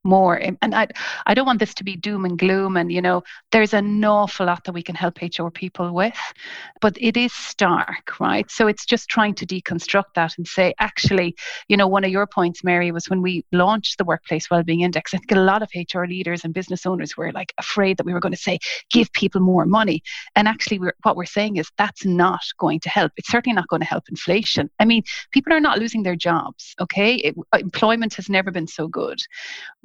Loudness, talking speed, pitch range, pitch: -20 LUFS, 230 wpm, 175-210 Hz, 190 Hz